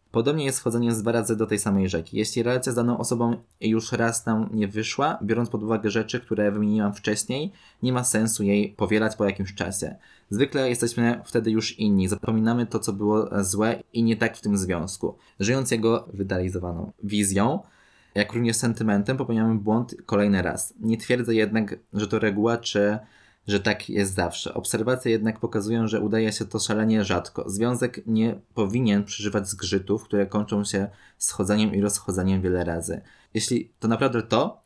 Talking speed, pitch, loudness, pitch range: 170 wpm, 110 Hz, -25 LUFS, 100-115 Hz